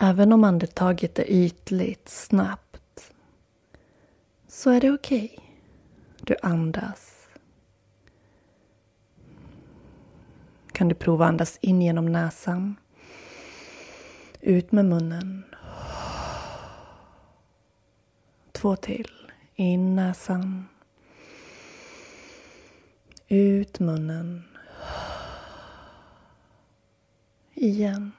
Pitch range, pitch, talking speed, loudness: 175-205 Hz, 190 Hz, 65 wpm, -24 LUFS